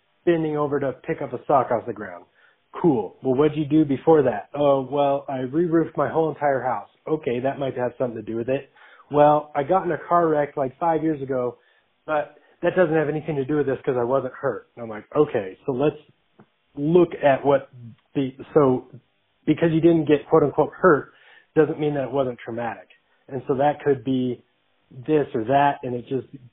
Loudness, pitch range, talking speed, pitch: -22 LUFS, 130-155 Hz, 215 wpm, 140 Hz